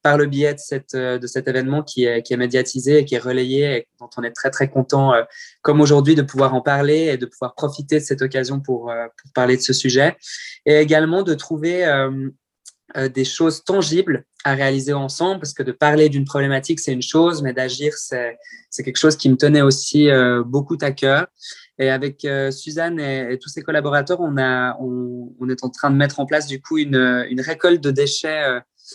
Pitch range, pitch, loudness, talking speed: 130-150 Hz, 140 Hz, -18 LUFS, 220 wpm